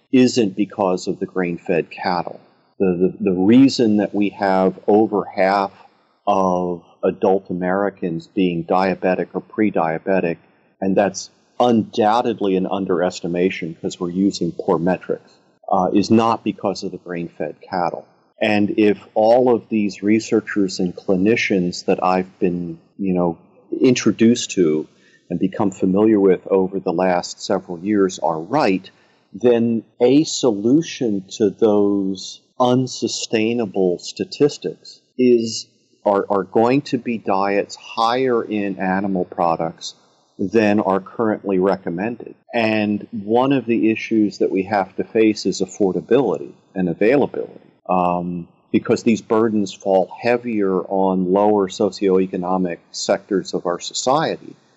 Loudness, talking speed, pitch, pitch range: -19 LUFS, 130 wpm, 100 Hz, 95-110 Hz